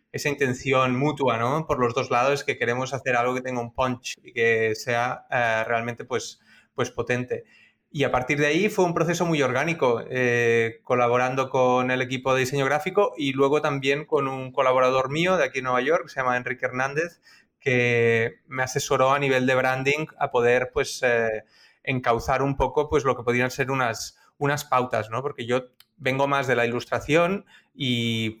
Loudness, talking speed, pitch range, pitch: -24 LUFS, 190 wpm, 120-140 Hz, 130 Hz